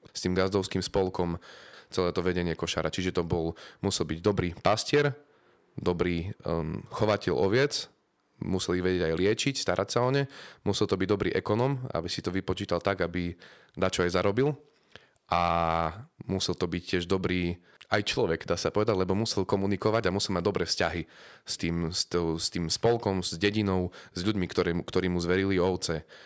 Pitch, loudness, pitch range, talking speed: 90 Hz, -29 LUFS, 85-100 Hz, 170 wpm